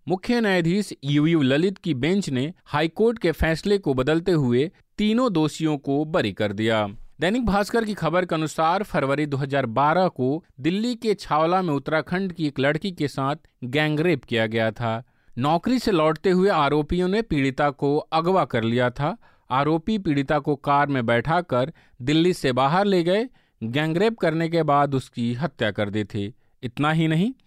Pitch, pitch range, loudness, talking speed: 155 Hz, 135-180 Hz, -23 LUFS, 165 wpm